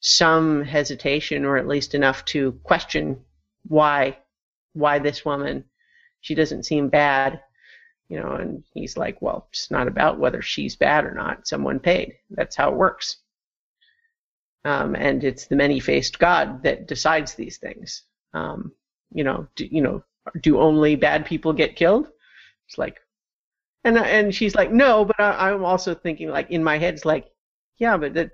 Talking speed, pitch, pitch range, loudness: 165 wpm, 155 Hz, 145-205 Hz, -21 LUFS